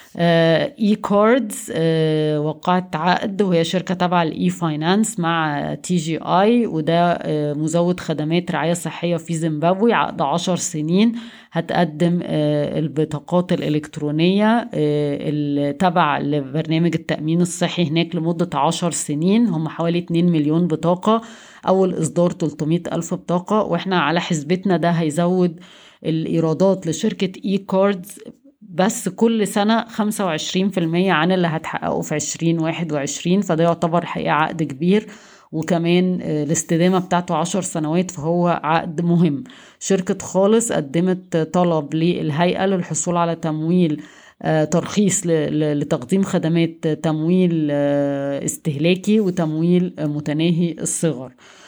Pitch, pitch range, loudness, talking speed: 170 Hz, 160-185 Hz, -19 LUFS, 110 wpm